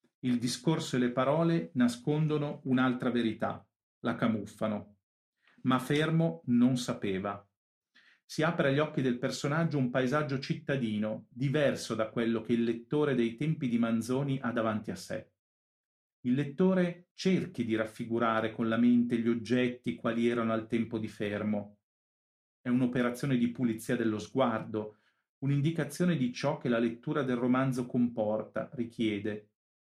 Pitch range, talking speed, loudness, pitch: 115-140 Hz, 140 wpm, -31 LUFS, 120 Hz